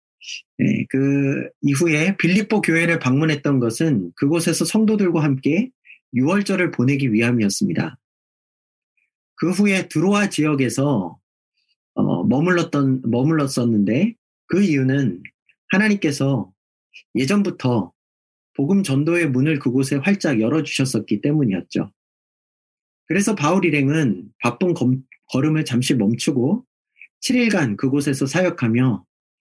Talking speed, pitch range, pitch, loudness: 255 characters per minute, 130-175 Hz, 150 Hz, -19 LUFS